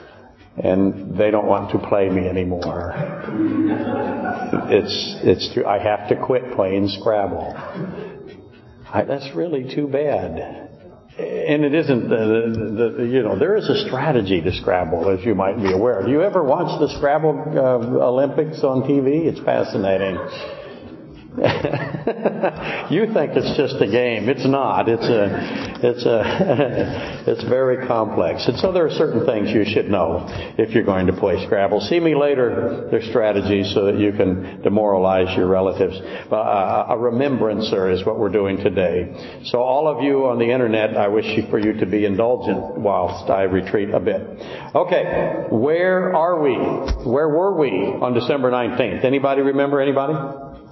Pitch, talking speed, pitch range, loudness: 120 Hz, 160 wpm, 100-140 Hz, -19 LUFS